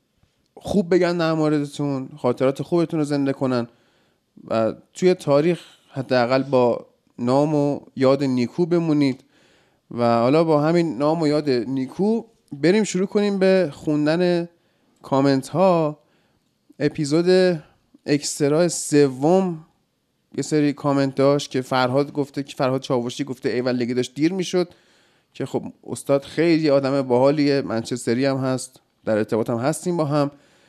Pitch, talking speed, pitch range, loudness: 145 Hz, 135 wpm, 130-160 Hz, -21 LUFS